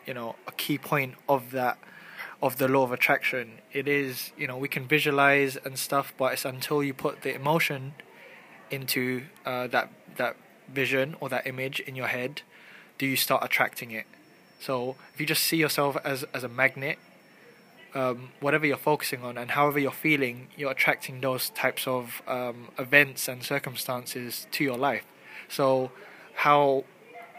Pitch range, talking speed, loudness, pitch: 130-145 Hz, 170 wpm, -27 LUFS, 135 Hz